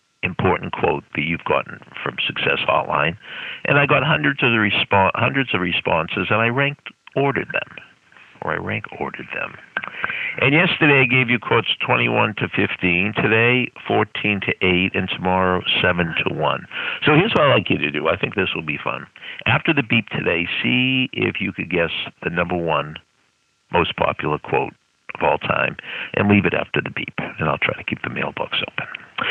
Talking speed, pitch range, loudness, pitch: 190 wpm, 95-135 Hz, -19 LUFS, 110 Hz